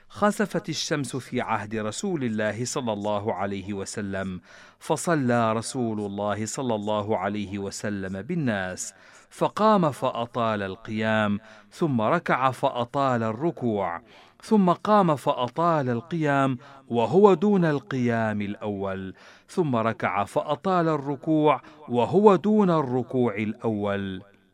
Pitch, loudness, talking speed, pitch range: 120 Hz, -25 LUFS, 100 wpm, 105-155 Hz